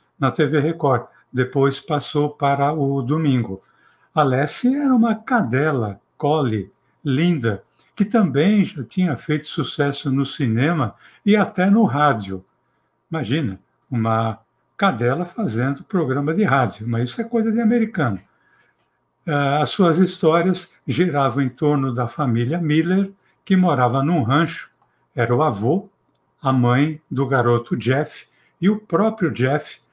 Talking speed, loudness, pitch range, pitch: 130 wpm, -20 LUFS, 125-175 Hz, 145 Hz